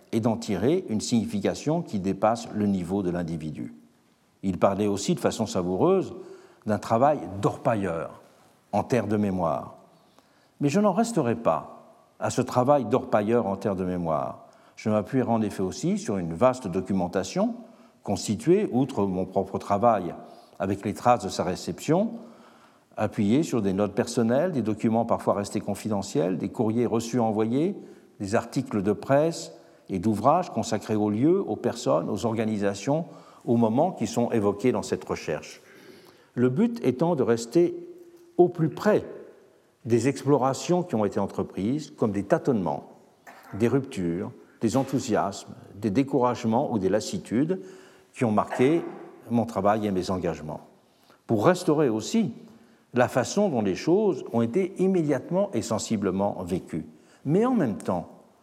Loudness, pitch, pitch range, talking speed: -26 LUFS, 115 Hz, 100-150 Hz, 150 wpm